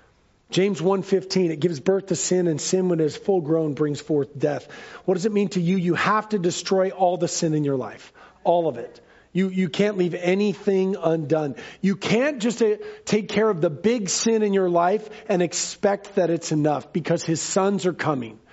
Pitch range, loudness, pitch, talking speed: 160-200 Hz, -23 LUFS, 180 Hz, 205 wpm